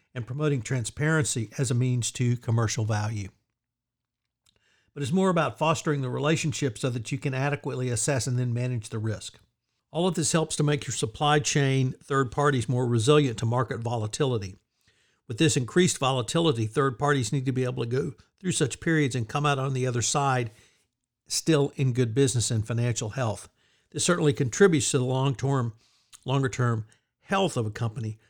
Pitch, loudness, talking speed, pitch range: 130 Hz, -26 LUFS, 180 wpm, 120-145 Hz